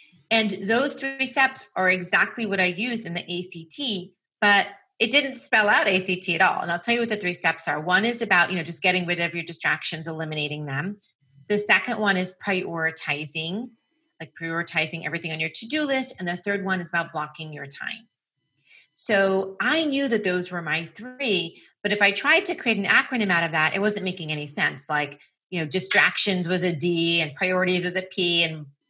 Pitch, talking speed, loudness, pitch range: 185 Hz, 210 wpm, -23 LUFS, 165-215 Hz